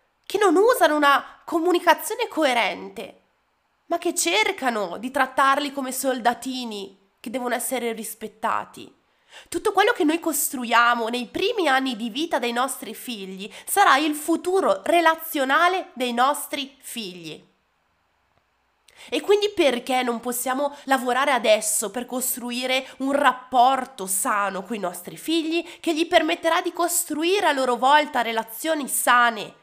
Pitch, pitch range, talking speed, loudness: 265 Hz, 240-325 Hz, 130 wpm, -22 LUFS